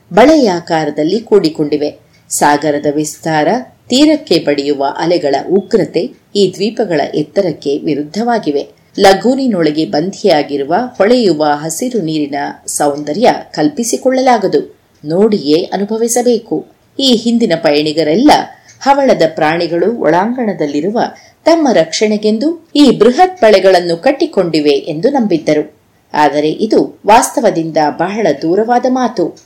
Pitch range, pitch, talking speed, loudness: 150-235 Hz, 185 Hz, 85 wpm, -12 LUFS